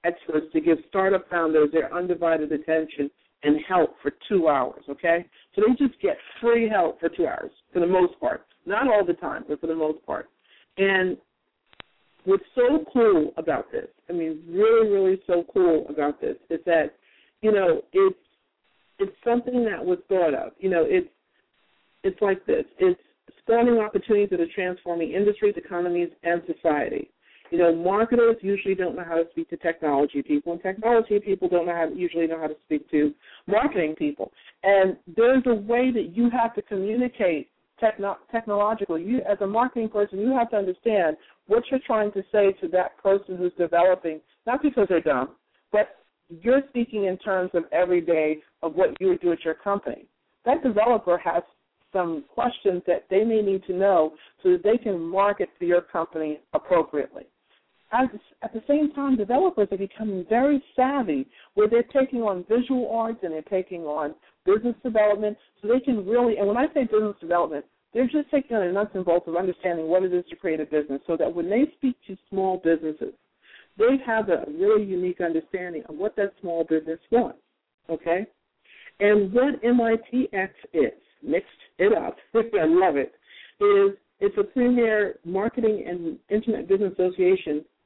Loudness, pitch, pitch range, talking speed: -24 LUFS, 195 Hz, 170-235 Hz, 180 wpm